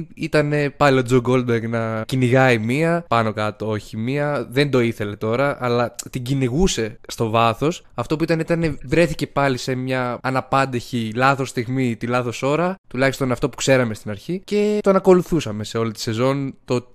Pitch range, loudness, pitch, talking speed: 115-145 Hz, -20 LUFS, 130 Hz, 175 wpm